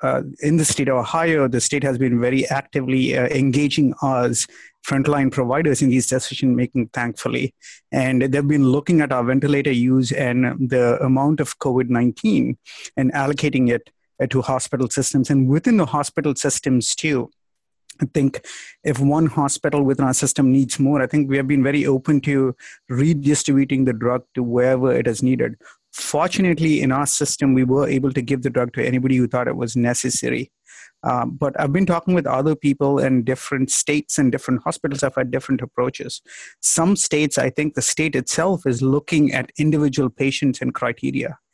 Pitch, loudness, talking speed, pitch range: 135 Hz, -19 LUFS, 180 wpm, 130-145 Hz